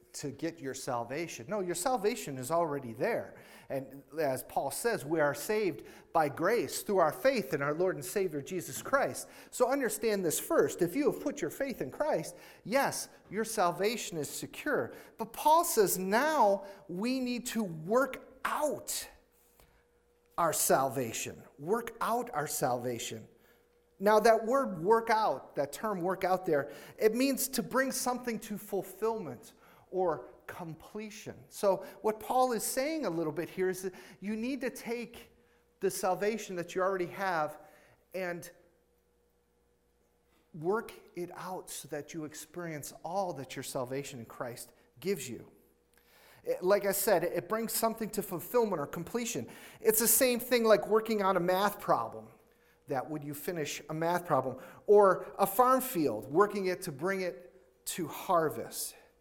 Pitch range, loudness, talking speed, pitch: 150-220 Hz, -32 LUFS, 155 wpm, 185 Hz